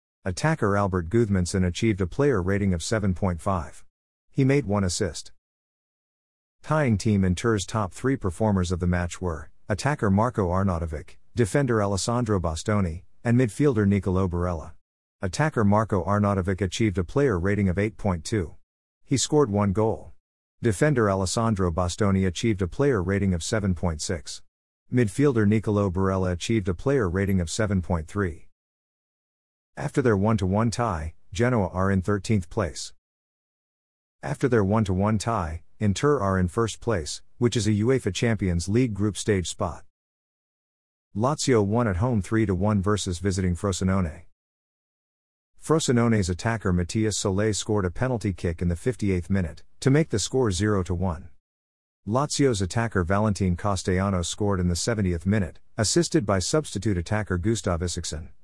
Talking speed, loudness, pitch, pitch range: 135 wpm, -25 LUFS, 100 Hz, 90-110 Hz